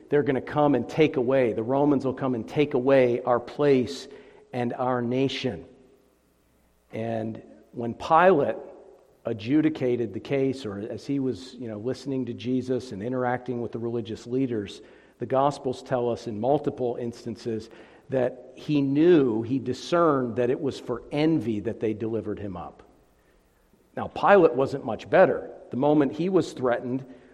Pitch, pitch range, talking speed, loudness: 125 Hz, 115-135 Hz, 160 wpm, -25 LUFS